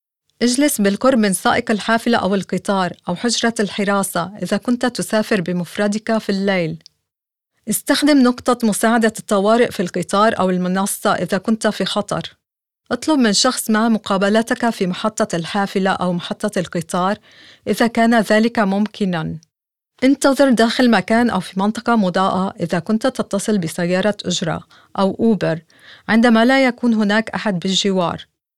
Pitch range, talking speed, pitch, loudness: 190-230 Hz, 130 wpm, 210 Hz, -17 LUFS